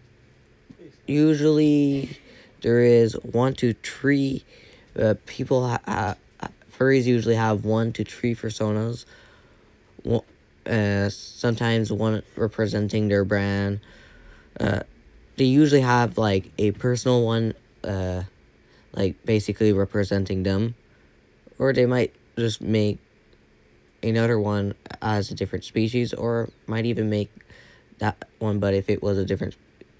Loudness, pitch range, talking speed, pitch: -23 LUFS, 100-120 Hz, 120 wpm, 110 Hz